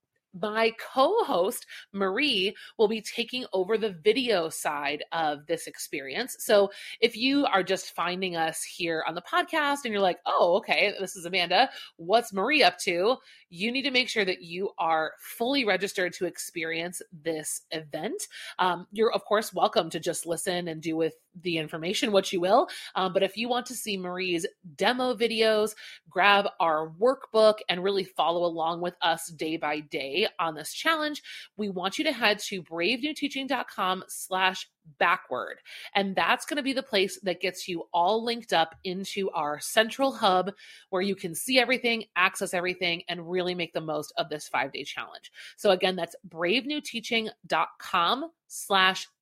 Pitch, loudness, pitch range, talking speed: 195 Hz, -27 LUFS, 175-230 Hz, 170 wpm